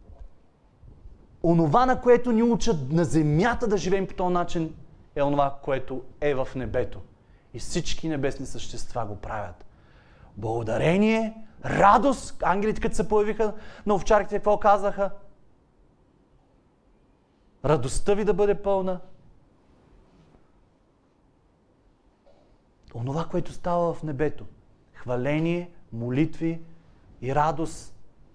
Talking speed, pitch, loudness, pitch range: 100 wpm, 160 Hz, -25 LUFS, 125-200 Hz